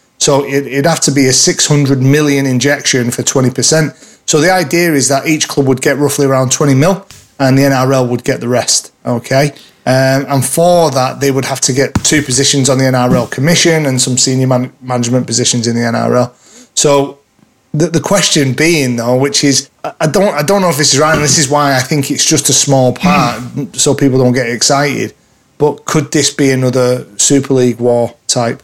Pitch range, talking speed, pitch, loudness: 130-150 Hz, 210 wpm, 140 Hz, -10 LUFS